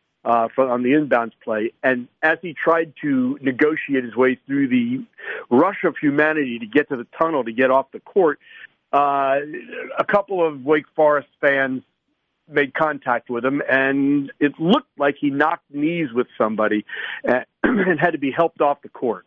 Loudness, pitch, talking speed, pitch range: -20 LUFS, 145 Hz, 180 wpm, 130-170 Hz